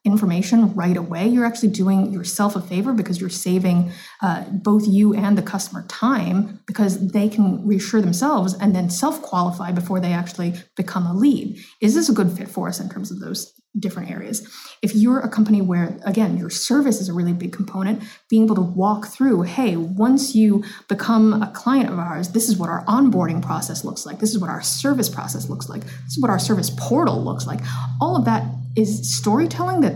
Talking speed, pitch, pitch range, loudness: 205 wpm, 195 Hz, 175-215 Hz, -20 LUFS